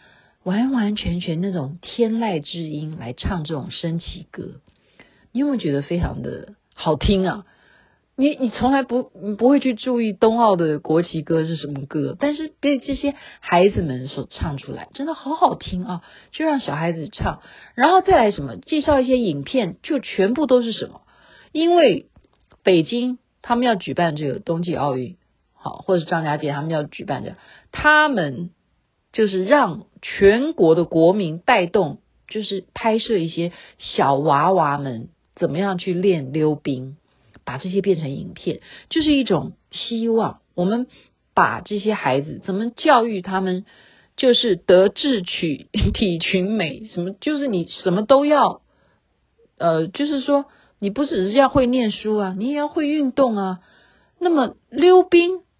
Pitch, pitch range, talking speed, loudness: 195 Hz, 165-260 Hz, 235 characters per minute, -20 LUFS